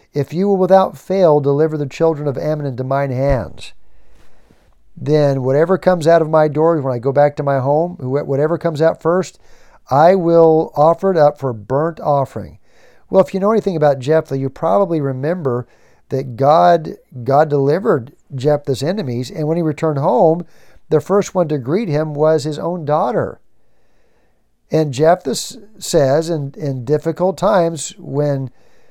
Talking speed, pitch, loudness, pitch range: 160 wpm, 150 Hz, -16 LUFS, 140-165 Hz